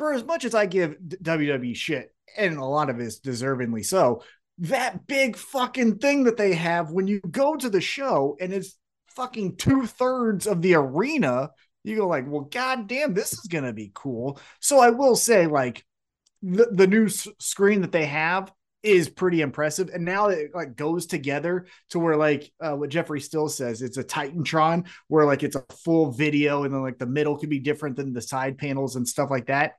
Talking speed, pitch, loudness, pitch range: 200 wpm, 170 Hz, -24 LUFS, 145-210 Hz